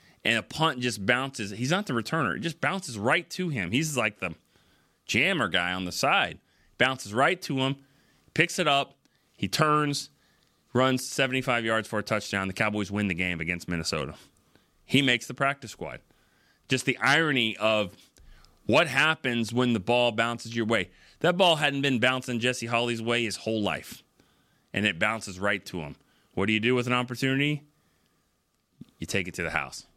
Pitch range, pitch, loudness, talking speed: 105-135 Hz, 120 Hz, -26 LUFS, 185 wpm